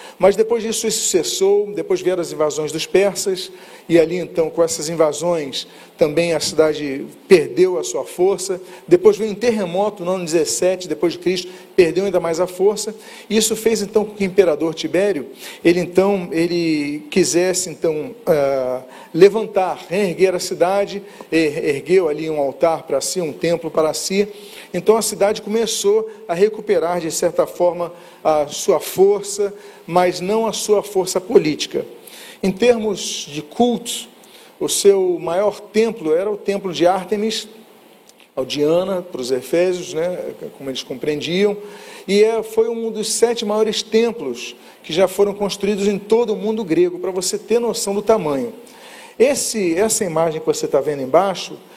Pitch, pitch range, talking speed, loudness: 195 Hz, 170-220 Hz, 160 wpm, -18 LUFS